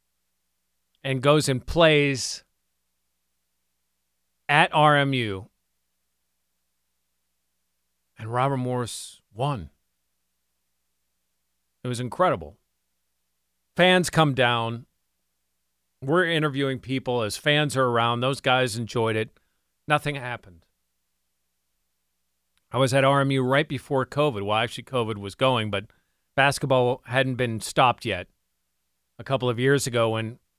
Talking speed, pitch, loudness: 105 wpm, 105 Hz, -23 LUFS